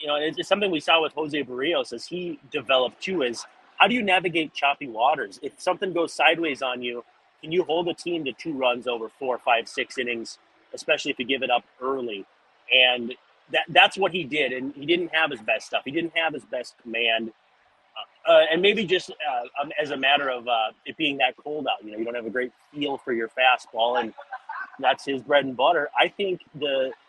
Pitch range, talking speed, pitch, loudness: 125-170 Hz, 220 wpm, 145 Hz, -24 LUFS